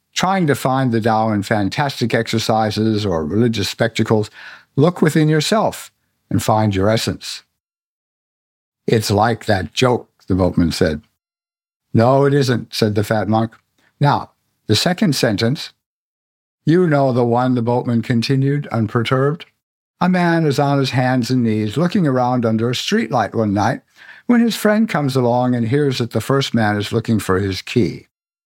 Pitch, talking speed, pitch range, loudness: 125 Hz, 160 wpm, 110-150 Hz, -17 LUFS